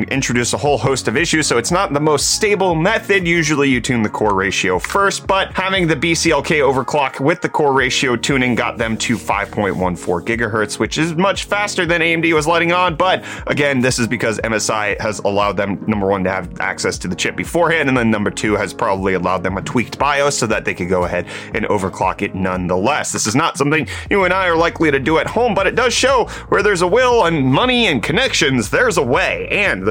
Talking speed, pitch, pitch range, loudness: 225 wpm, 135 Hz, 105-170 Hz, -16 LUFS